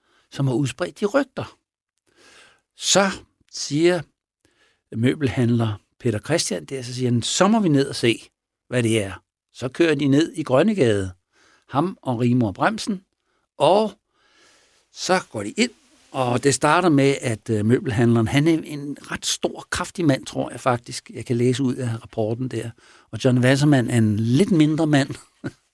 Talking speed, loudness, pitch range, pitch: 155 wpm, -21 LUFS, 120-155 Hz, 130 Hz